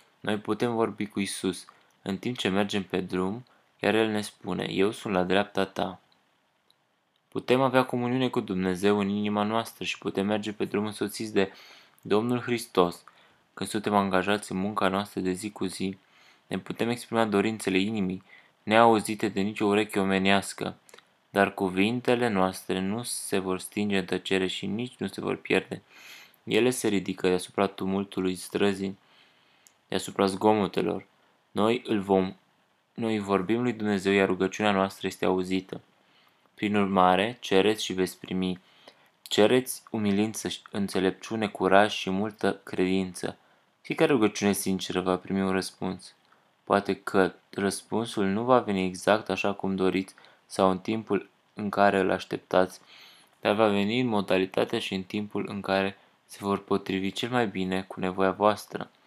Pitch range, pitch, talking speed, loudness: 95-105 Hz, 100 Hz, 150 wpm, -27 LUFS